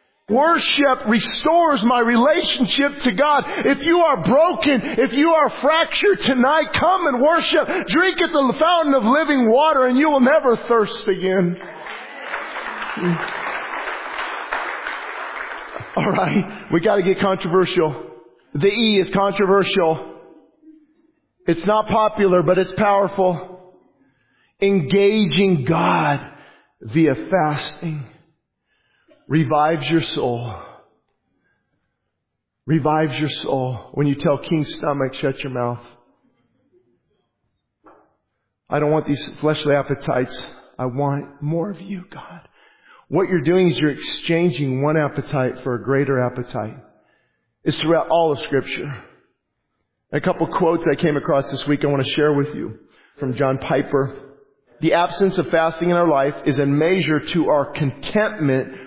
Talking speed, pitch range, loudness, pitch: 125 wpm, 145-240 Hz, -19 LUFS, 175 Hz